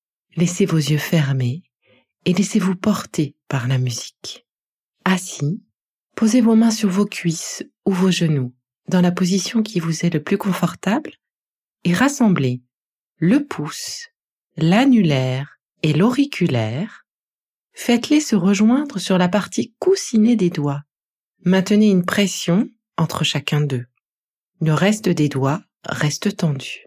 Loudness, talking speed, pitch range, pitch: -19 LUFS, 125 wpm, 155-215 Hz, 185 Hz